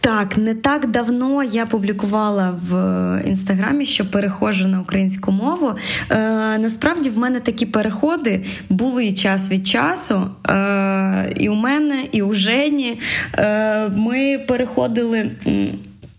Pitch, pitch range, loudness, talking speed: 215 Hz, 195-250 Hz, -18 LUFS, 130 wpm